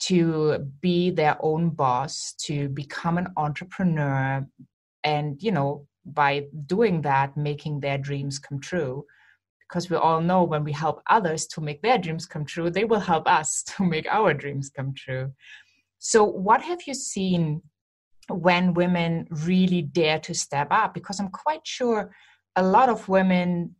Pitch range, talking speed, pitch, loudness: 145-180 Hz, 160 wpm, 160 Hz, -24 LUFS